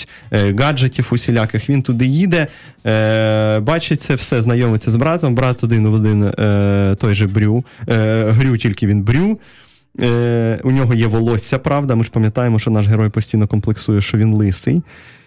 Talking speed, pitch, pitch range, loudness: 145 wpm, 115 Hz, 110-130 Hz, -15 LUFS